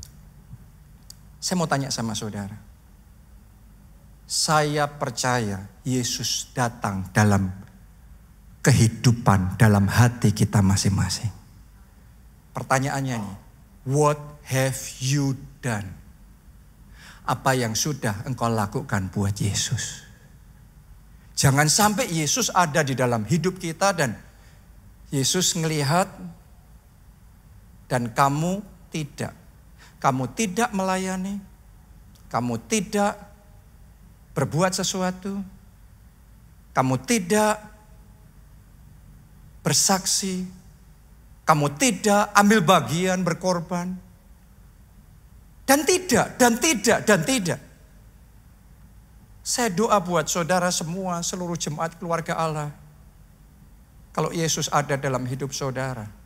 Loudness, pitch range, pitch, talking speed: -23 LUFS, 110-175 Hz, 140 Hz, 85 wpm